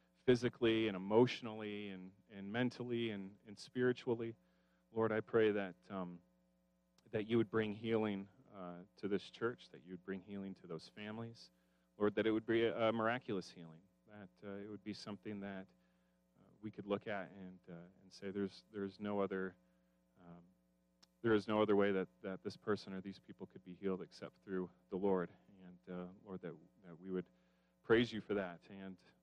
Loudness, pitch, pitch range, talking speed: -40 LUFS, 100 Hz, 90-110 Hz, 190 wpm